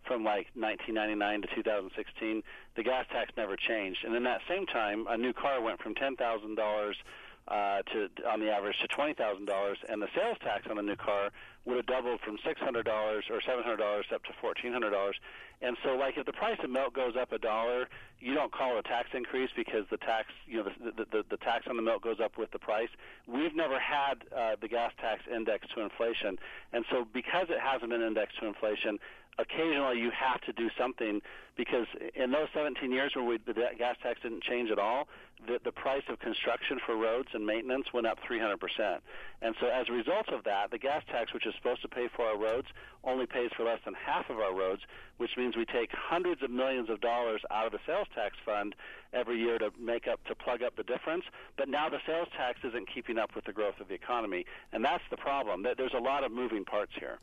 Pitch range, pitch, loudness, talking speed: 110-130 Hz, 120 Hz, -34 LUFS, 235 wpm